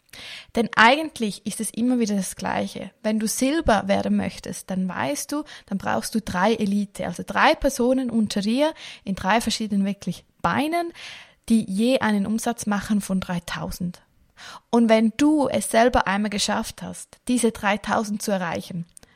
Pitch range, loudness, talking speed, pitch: 200-240 Hz, -23 LUFS, 155 wpm, 220 Hz